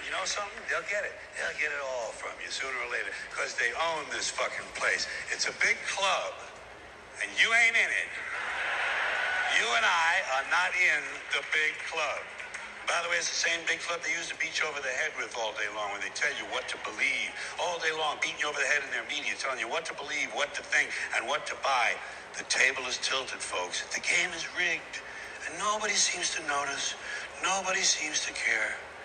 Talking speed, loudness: 220 wpm, -29 LUFS